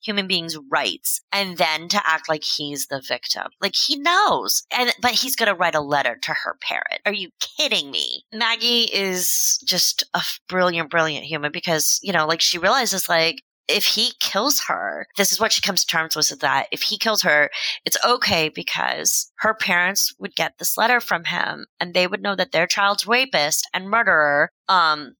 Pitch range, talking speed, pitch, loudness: 160-225 Hz, 200 wpm, 190 Hz, -19 LUFS